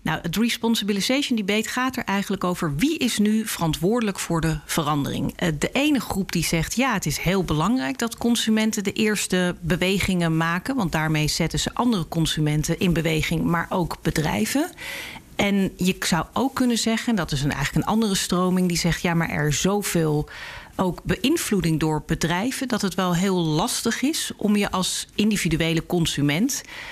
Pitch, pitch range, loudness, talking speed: 185 Hz, 165-225 Hz, -23 LUFS, 170 wpm